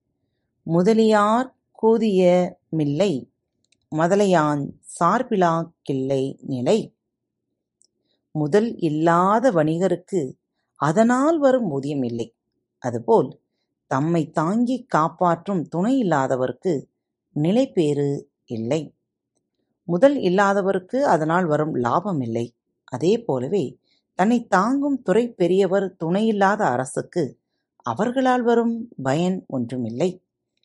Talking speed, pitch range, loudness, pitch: 70 wpm, 150-220 Hz, -21 LUFS, 180 Hz